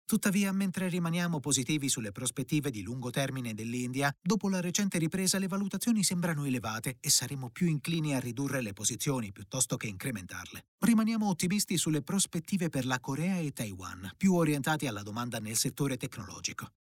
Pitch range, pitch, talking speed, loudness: 125-180 Hz, 145 Hz, 160 wpm, -31 LUFS